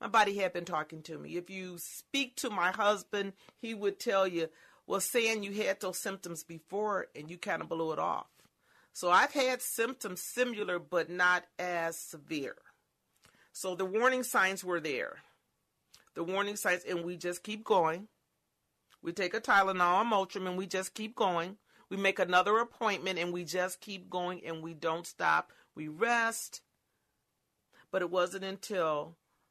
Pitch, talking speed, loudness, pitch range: 190 Hz, 170 wpm, -33 LUFS, 175-210 Hz